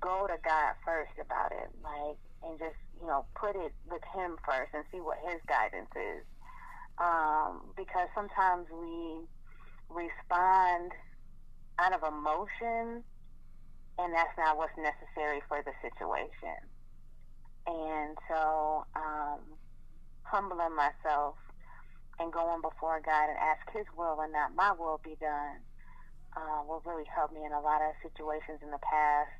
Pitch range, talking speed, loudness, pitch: 150-170 Hz, 145 wpm, -34 LUFS, 160 Hz